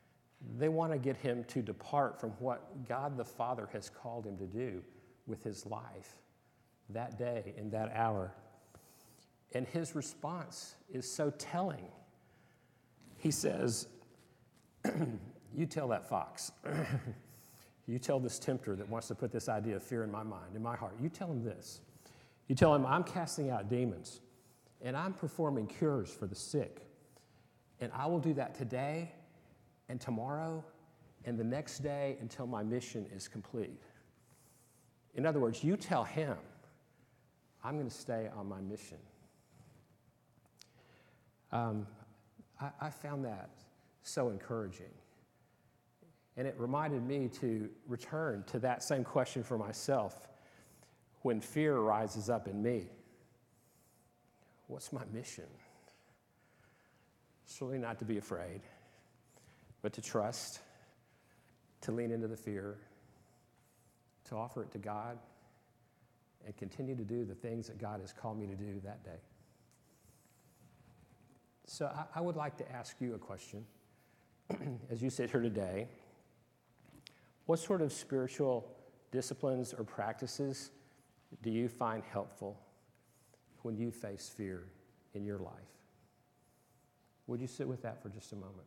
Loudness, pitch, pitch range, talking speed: -39 LUFS, 120 Hz, 110-135 Hz, 140 wpm